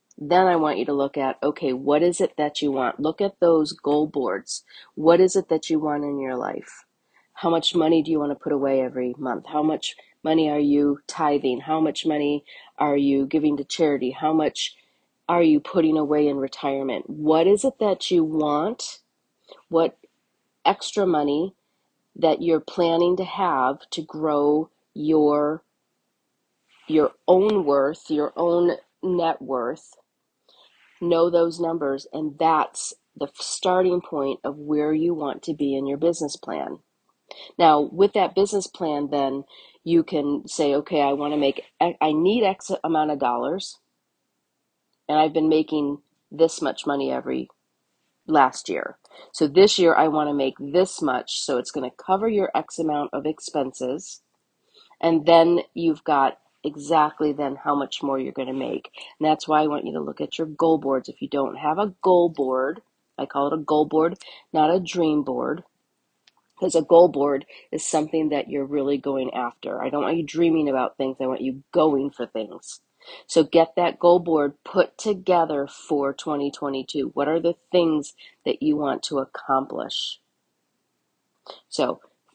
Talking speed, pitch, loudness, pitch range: 175 wpm, 150 Hz, -23 LUFS, 140-165 Hz